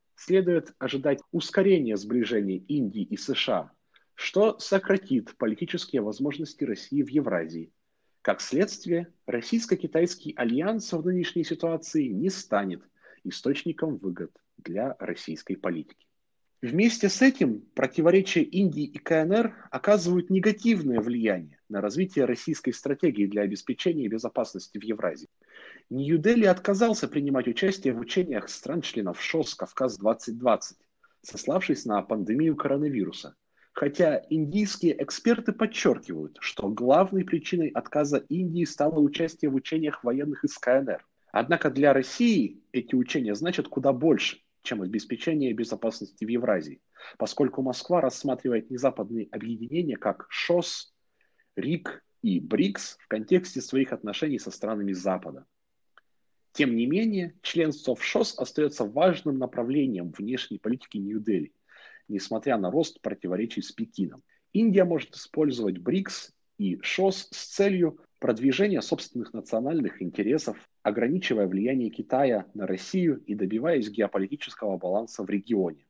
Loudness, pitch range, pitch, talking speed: -27 LUFS, 125-190 Hz, 155 Hz, 115 wpm